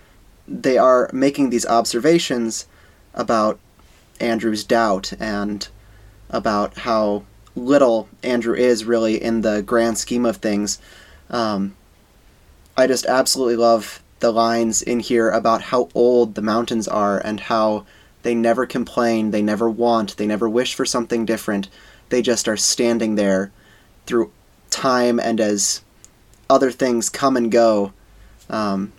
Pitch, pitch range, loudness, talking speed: 115 Hz, 105-120 Hz, -19 LUFS, 135 wpm